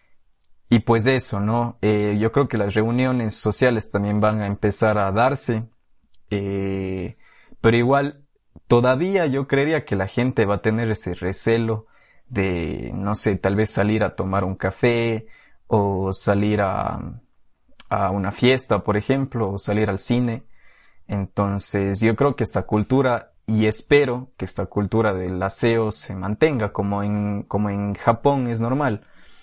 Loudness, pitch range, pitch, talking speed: -21 LUFS, 100-120 Hz, 105 Hz, 155 wpm